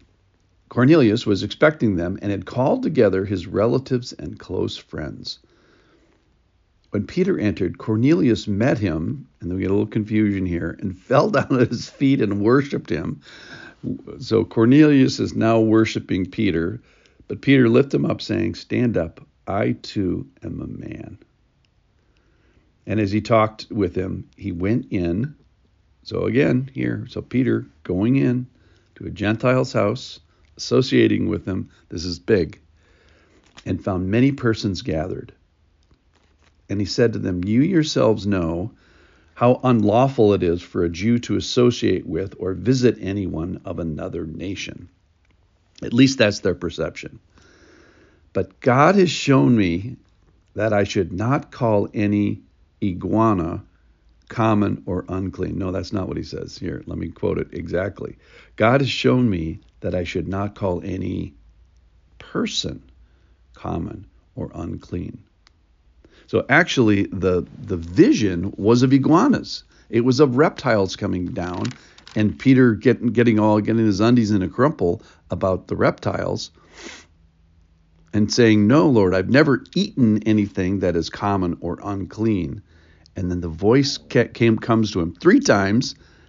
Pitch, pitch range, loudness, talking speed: 100 Hz, 85-115 Hz, -20 LUFS, 145 wpm